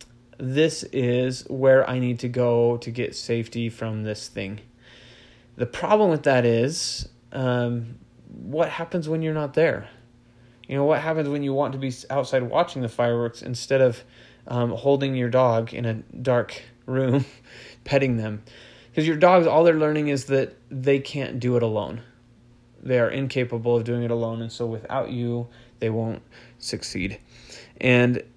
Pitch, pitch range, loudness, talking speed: 125 Hz, 120-135 Hz, -23 LUFS, 165 wpm